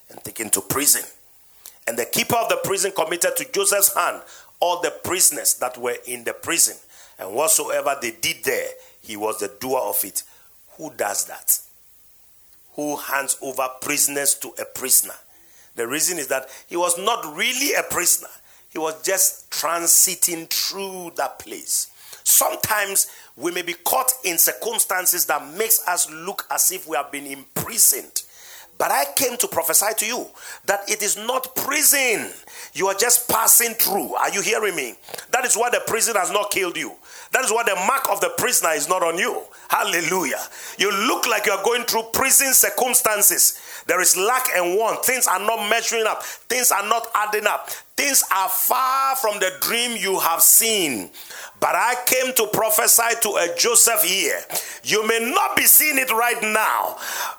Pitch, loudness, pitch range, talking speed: 215 Hz, -19 LUFS, 180-250 Hz, 175 wpm